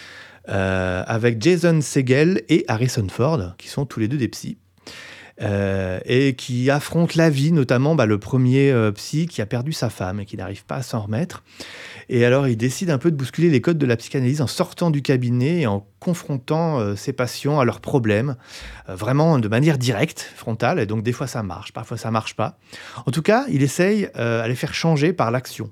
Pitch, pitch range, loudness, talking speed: 130 Hz, 110-155 Hz, -20 LUFS, 215 wpm